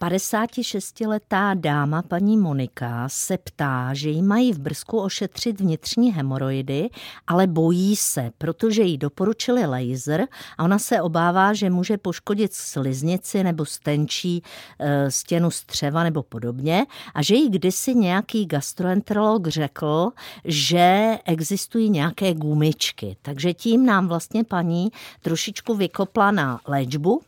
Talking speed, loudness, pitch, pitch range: 120 wpm, -22 LUFS, 175 Hz, 150-205 Hz